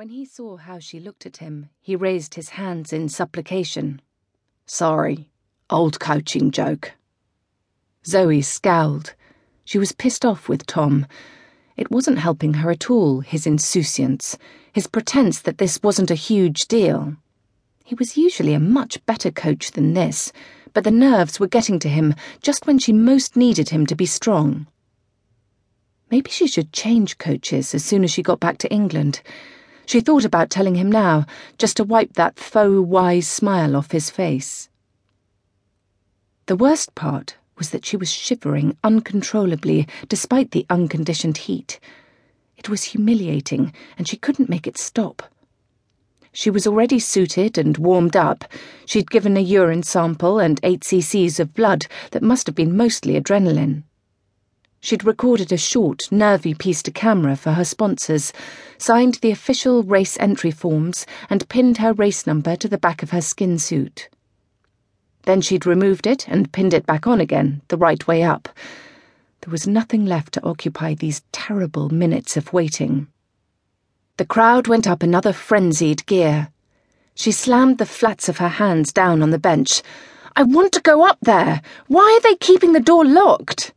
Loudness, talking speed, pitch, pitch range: -18 LUFS, 160 wpm, 180 Hz, 150-225 Hz